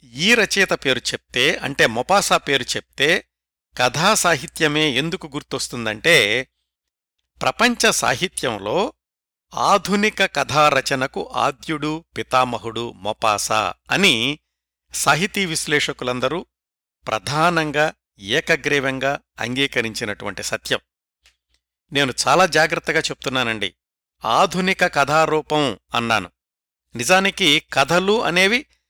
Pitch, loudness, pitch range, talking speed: 145 Hz, -19 LUFS, 115-175 Hz, 75 wpm